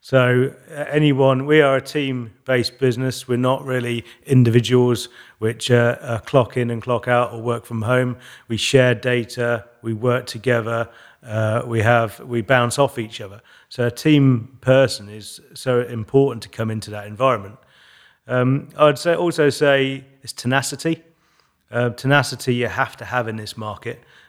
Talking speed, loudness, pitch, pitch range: 165 wpm, -19 LUFS, 125 Hz, 115-135 Hz